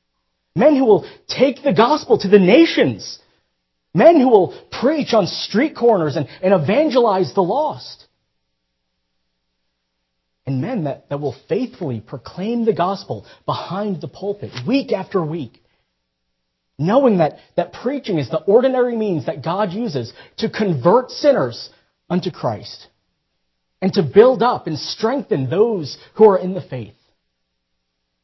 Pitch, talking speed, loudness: 170 Hz, 135 wpm, -17 LUFS